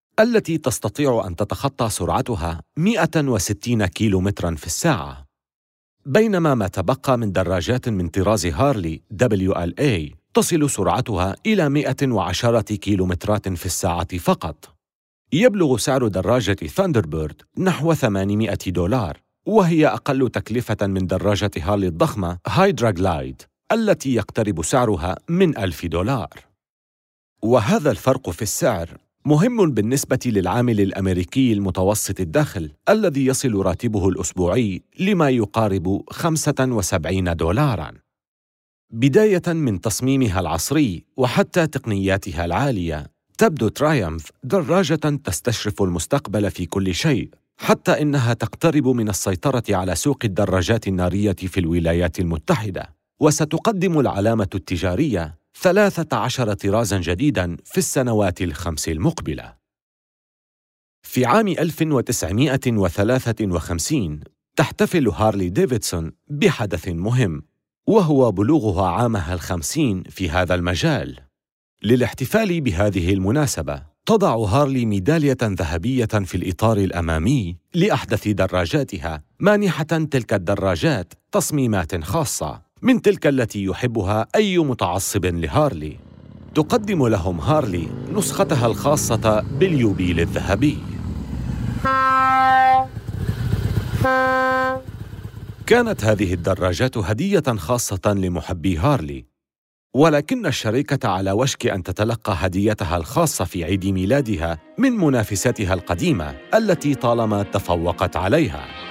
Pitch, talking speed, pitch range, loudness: 110 Hz, 95 wpm, 95-145 Hz, -20 LUFS